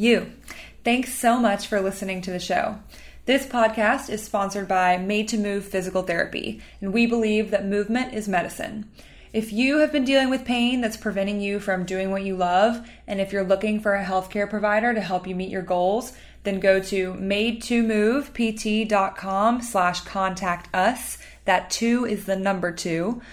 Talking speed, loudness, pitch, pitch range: 180 wpm, -23 LUFS, 205 Hz, 190-230 Hz